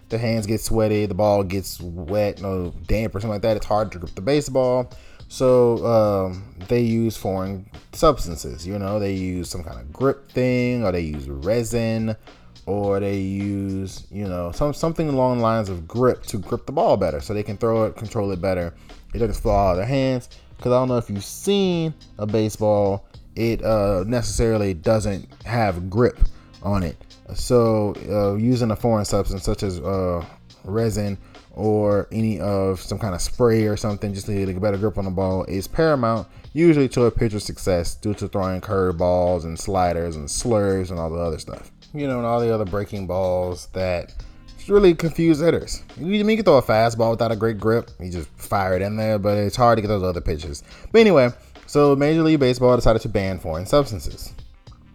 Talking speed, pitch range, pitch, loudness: 205 wpm, 95-115 Hz, 105 Hz, -21 LUFS